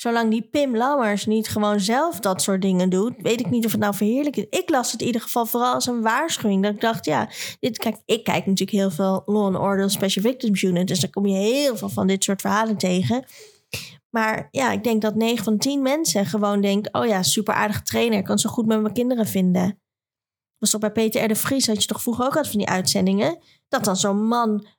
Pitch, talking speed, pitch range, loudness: 215 Hz, 245 wpm, 195-235 Hz, -21 LUFS